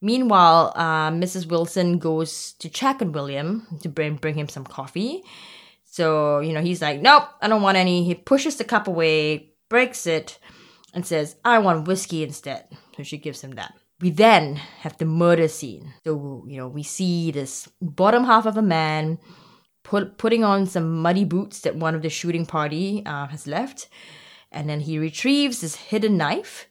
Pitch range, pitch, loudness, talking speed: 155-200 Hz, 165 Hz, -21 LUFS, 185 wpm